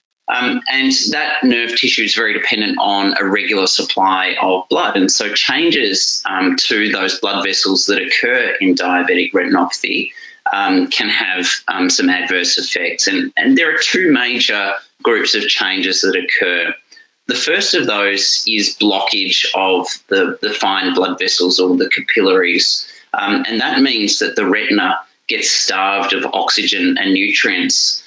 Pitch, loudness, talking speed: 275 Hz, -14 LUFS, 155 wpm